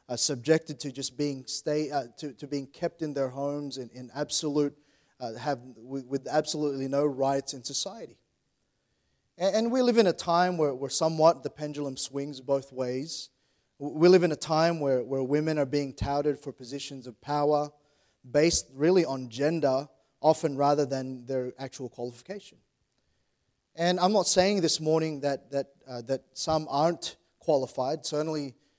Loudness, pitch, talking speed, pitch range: -28 LUFS, 145 Hz, 165 wpm, 135-155 Hz